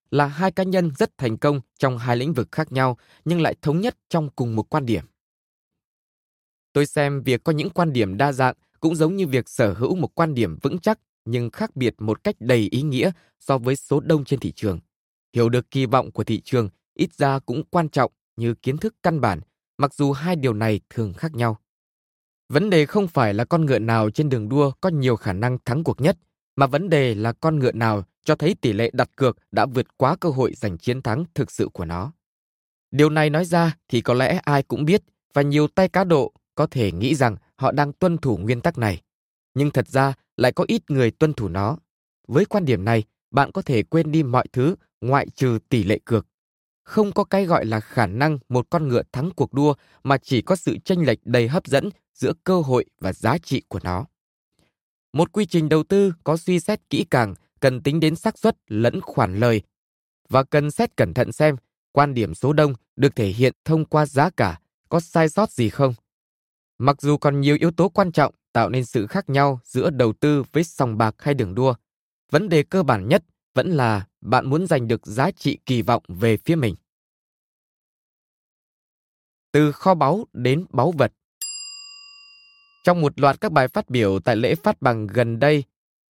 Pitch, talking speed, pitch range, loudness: 140 Hz, 215 wpm, 120-165 Hz, -21 LUFS